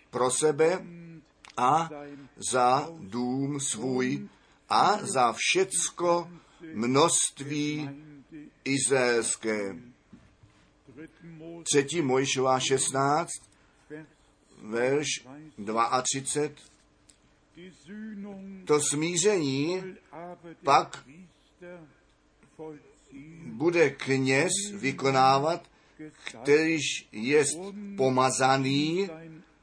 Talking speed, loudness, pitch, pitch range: 50 wpm, -26 LUFS, 150 Hz, 135-165 Hz